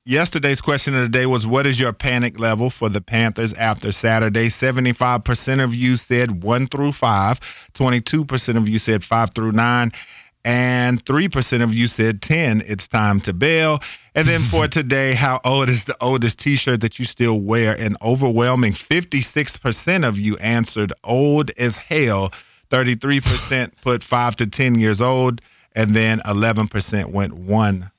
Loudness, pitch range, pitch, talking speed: -18 LUFS, 110-130 Hz, 120 Hz, 160 wpm